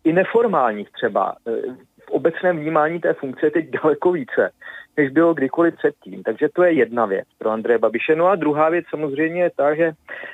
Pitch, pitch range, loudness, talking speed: 160 Hz, 150-175 Hz, -20 LUFS, 185 wpm